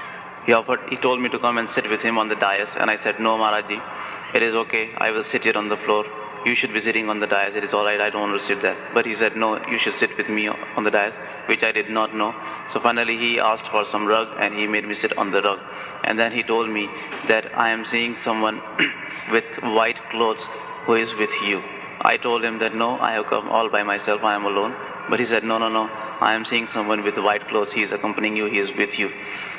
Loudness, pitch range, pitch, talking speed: -21 LUFS, 105-115 Hz, 110 Hz, 265 wpm